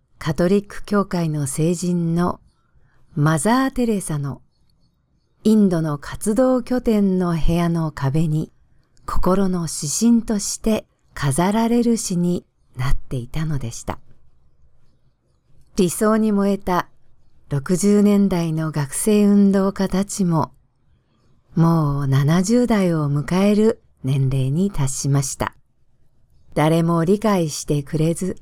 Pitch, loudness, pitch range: 170 Hz, -20 LUFS, 140-200 Hz